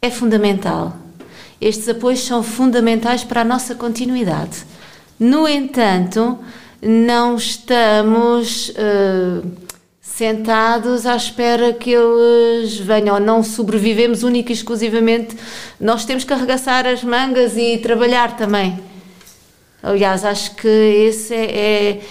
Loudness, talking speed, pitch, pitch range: -15 LUFS, 110 wpm, 230 Hz, 215-240 Hz